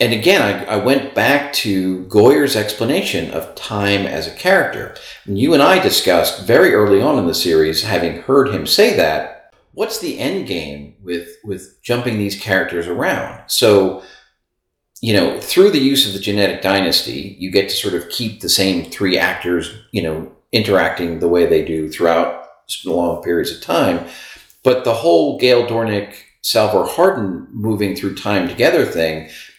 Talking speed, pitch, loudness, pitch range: 170 wpm, 100 Hz, -16 LUFS, 85-110 Hz